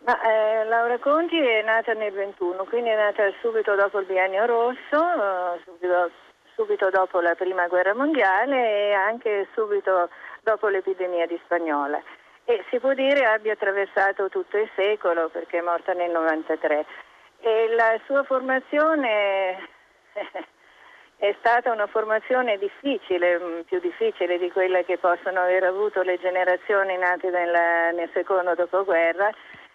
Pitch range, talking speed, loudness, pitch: 180-225 Hz, 135 wpm, -23 LUFS, 195 Hz